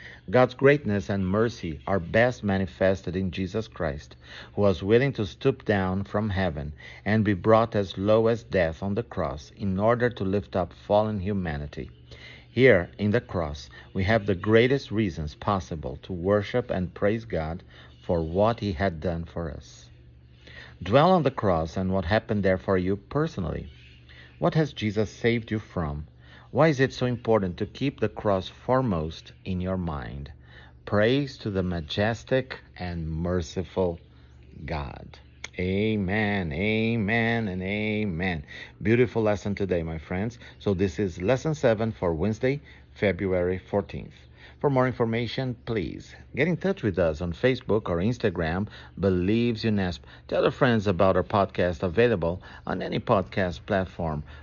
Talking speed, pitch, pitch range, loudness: 150 wpm, 95 Hz, 85-110 Hz, -26 LUFS